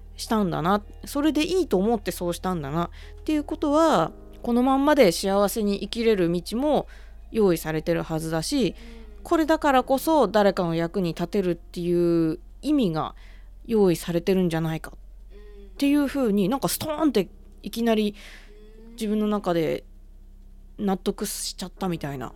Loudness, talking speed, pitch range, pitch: -24 LUFS, 325 characters per minute, 170-235 Hz, 205 Hz